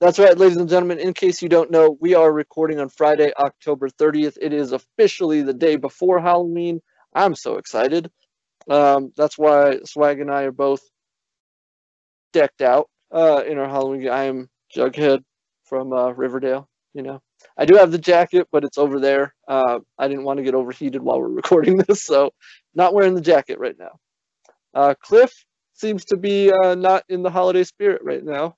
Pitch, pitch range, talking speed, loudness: 150 Hz, 140-180 Hz, 185 wpm, -18 LUFS